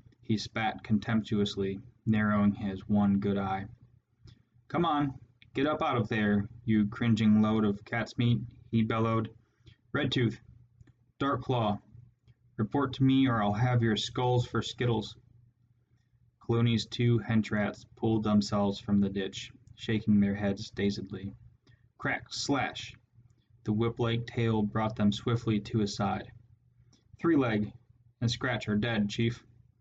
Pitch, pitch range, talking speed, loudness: 115 Hz, 105-120 Hz, 135 wpm, -30 LUFS